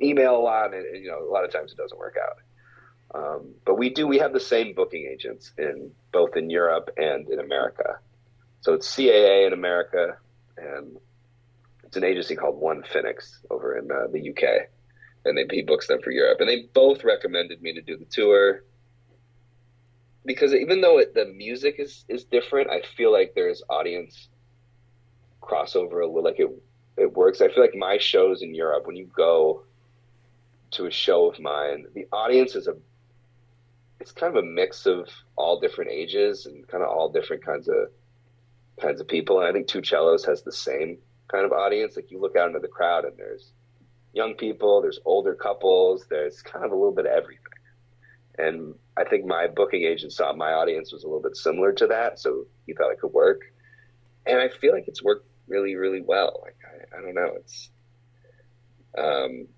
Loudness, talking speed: -23 LUFS, 195 wpm